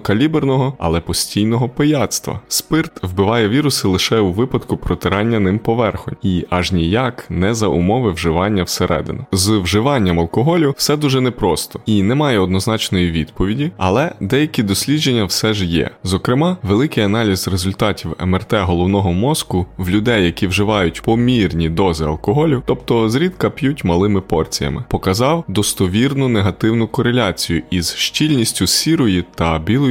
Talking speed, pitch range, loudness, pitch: 130 wpm, 95-125 Hz, -16 LUFS, 105 Hz